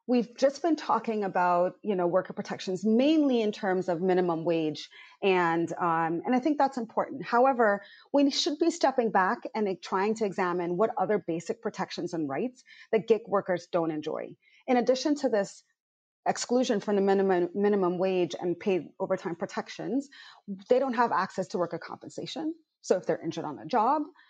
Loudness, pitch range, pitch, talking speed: -28 LUFS, 180-255 Hz, 205 Hz, 175 wpm